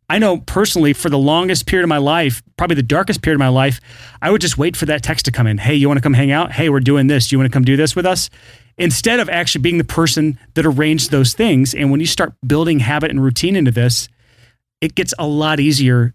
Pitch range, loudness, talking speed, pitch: 130-165 Hz, -15 LUFS, 255 wpm, 150 Hz